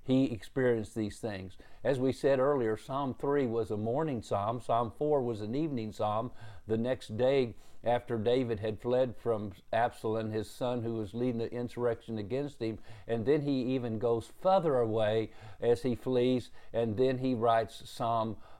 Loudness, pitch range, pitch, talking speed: -32 LUFS, 110-130 Hz, 115 Hz, 170 wpm